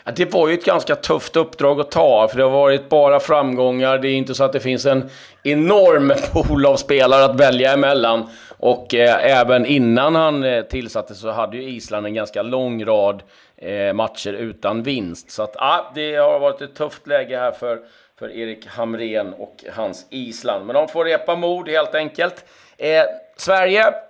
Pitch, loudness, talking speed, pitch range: 135 Hz, -17 LUFS, 185 wpm, 125-160 Hz